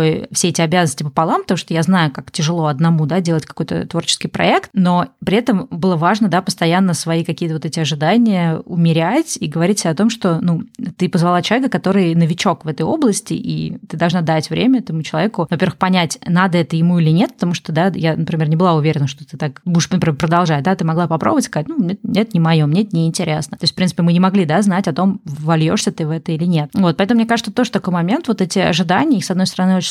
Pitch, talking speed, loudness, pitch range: 175 Hz, 230 wpm, -16 LUFS, 165-195 Hz